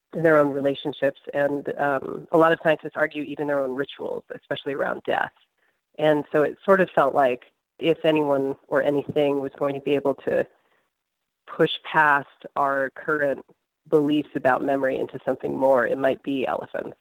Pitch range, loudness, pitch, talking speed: 140-155 Hz, -23 LUFS, 145 Hz, 170 wpm